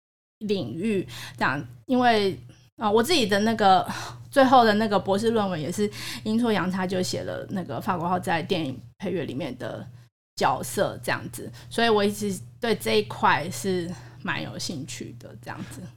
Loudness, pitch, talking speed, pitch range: -25 LUFS, 190 Hz, 255 characters per minute, 130-215 Hz